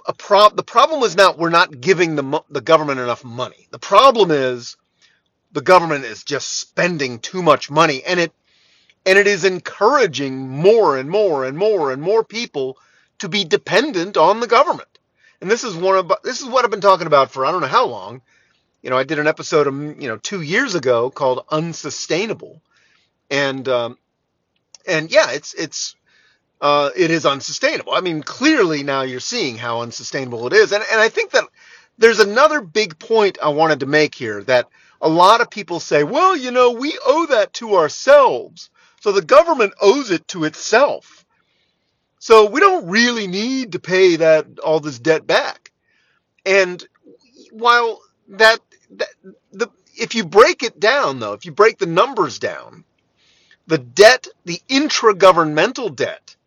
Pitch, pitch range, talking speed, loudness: 185 Hz, 150-225 Hz, 175 wpm, -16 LUFS